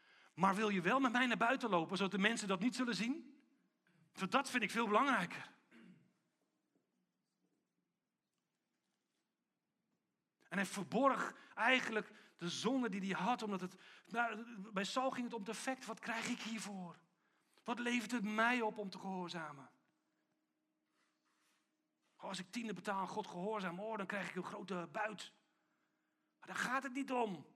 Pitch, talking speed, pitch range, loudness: 215 Hz, 150 wpm, 195-240 Hz, -39 LUFS